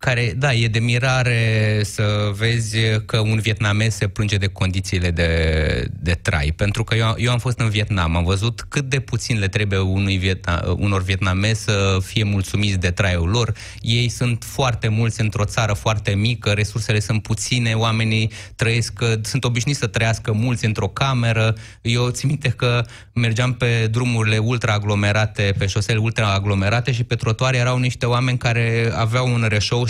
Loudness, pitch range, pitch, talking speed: -19 LUFS, 105-120 Hz, 110 Hz, 165 wpm